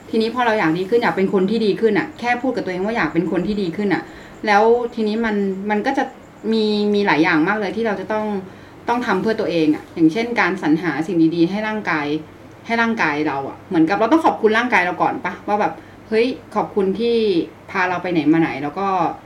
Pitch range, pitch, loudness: 170-225 Hz, 200 Hz, -19 LUFS